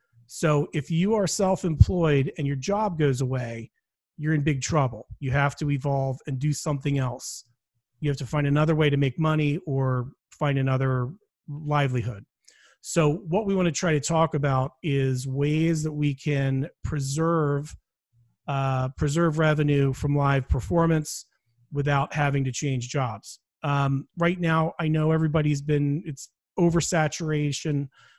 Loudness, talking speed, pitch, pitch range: -25 LUFS, 150 wpm, 145 Hz, 135-155 Hz